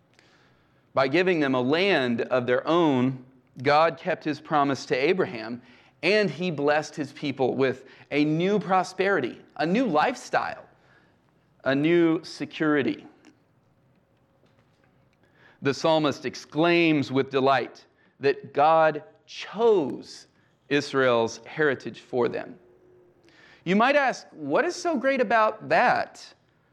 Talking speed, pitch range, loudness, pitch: 110 wpm, 135-185 Hz, -24 LUFS, 155 Hz